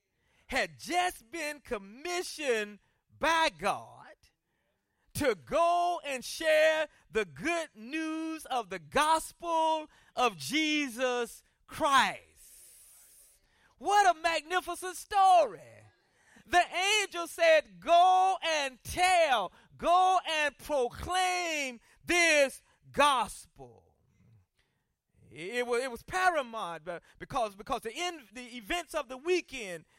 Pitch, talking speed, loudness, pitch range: 310 Hz, 95 wpm, -29 LUFS, 245-345 Hz